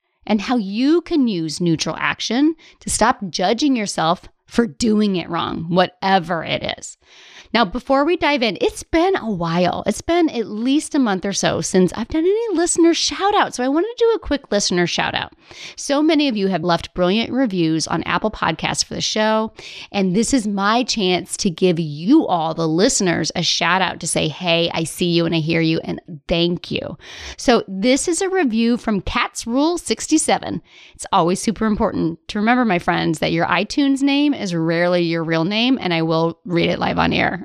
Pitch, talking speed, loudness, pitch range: 210 Hz, 205 wpm, -18 LUFS, 175-275 Hz